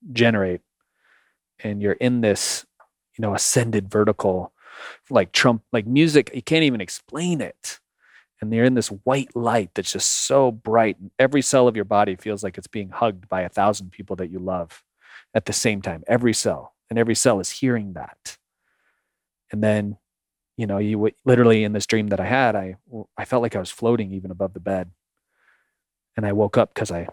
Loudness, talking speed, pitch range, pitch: -21 LUFS, 190 wpm, 100-120 Hz, 110 Hz